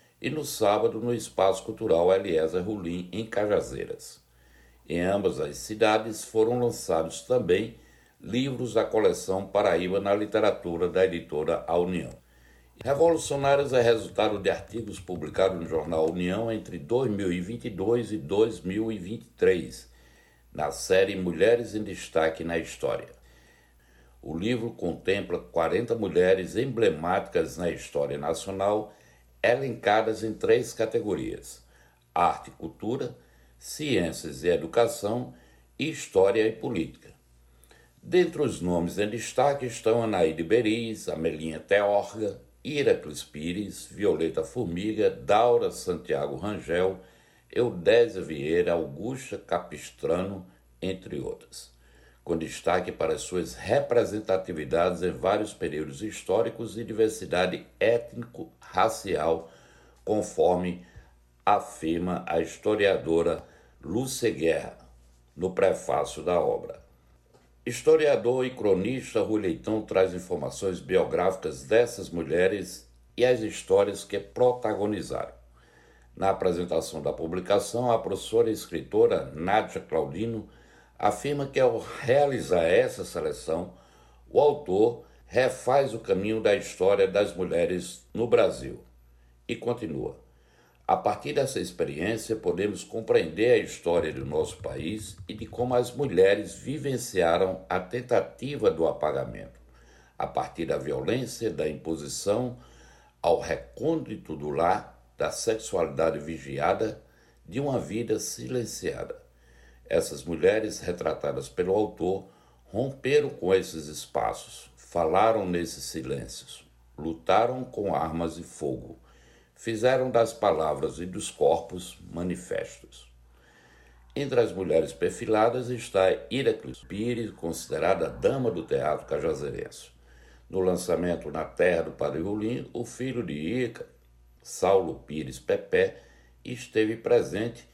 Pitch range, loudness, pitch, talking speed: 80-120 Hz, -27 LUFS, 95 Hz, 110 wpm